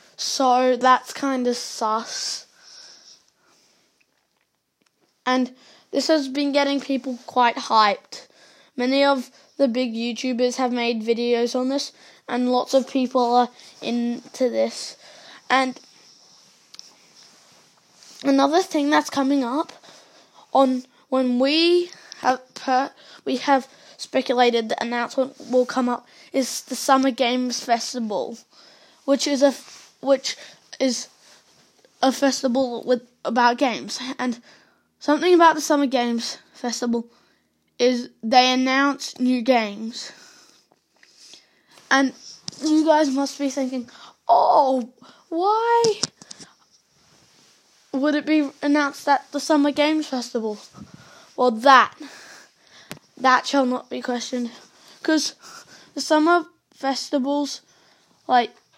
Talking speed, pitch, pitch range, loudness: 105 wpm, 260 Hz, 245-285 Hz, -21 LUFS